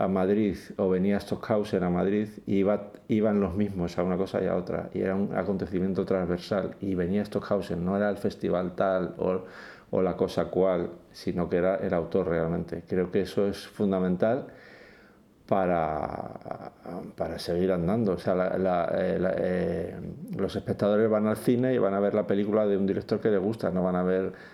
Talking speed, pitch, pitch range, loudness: 195 wpm, 95 Hz, 90-100 Hz, -28 LUFS